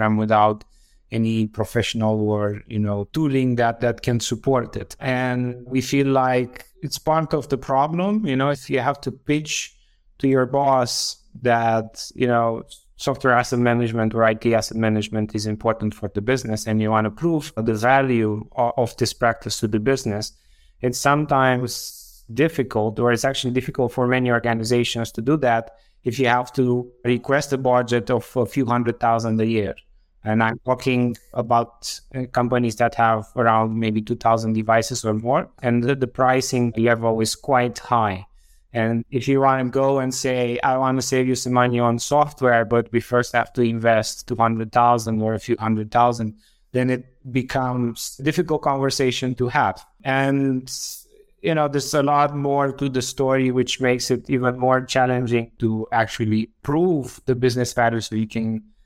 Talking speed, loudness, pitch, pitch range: 175 wpm, -21 LUFS, 120 Hz, 115-130 Hz